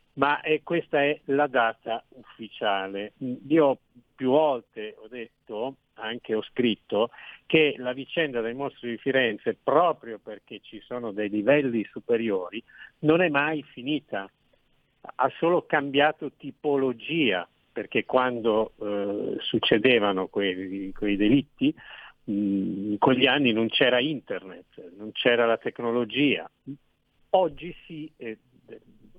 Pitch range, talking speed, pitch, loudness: 110-150 Hz, 115 wpm, 130 Hz, -25 LUFS